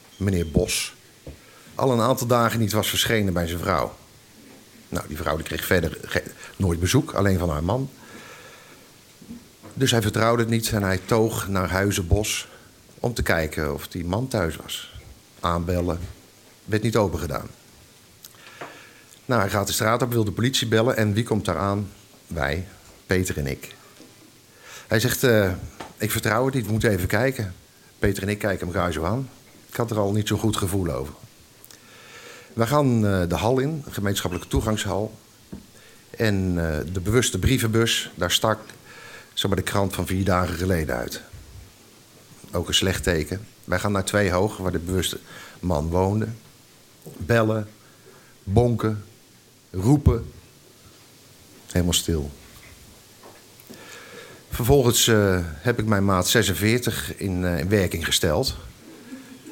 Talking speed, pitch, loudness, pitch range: 150 wpm, 100 Hz, -23 LUFS, 90-115 Hz